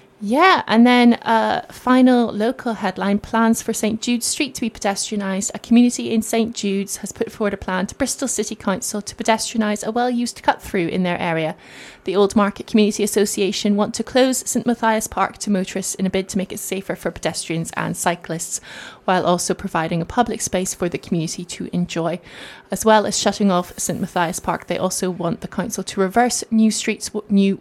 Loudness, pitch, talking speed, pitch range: -20 LUFS, 205 Hz, 200 wpm, 190-225 Hz